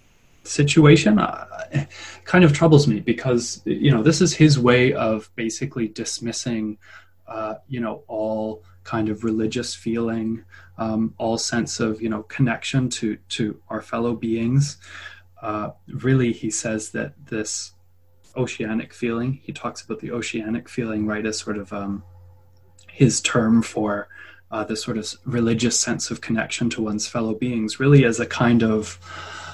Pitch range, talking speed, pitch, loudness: 110-125 Hz, 150 wpm, 115 Hz, -22 LUFS